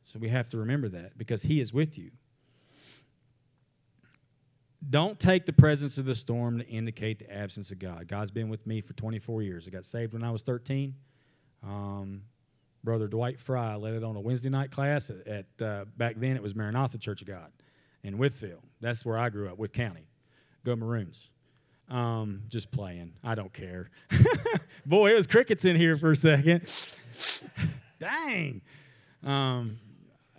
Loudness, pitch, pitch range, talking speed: -29 LUFS, 120 Hz, 110-135 Hz, 170 wpm